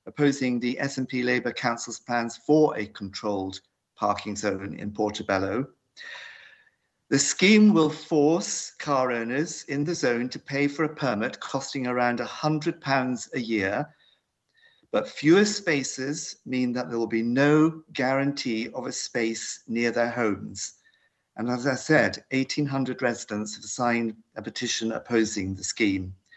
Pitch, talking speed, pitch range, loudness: 125 Hz, 140 wpm, 115-150 Hz, -26 LUFS